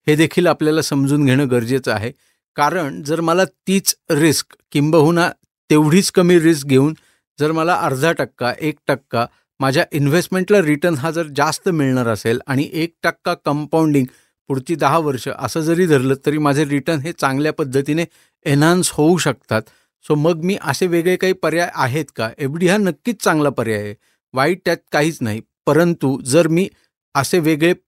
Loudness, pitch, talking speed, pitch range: -17 LUFS, 155 Hz, 160 wpm, 140-170 Hz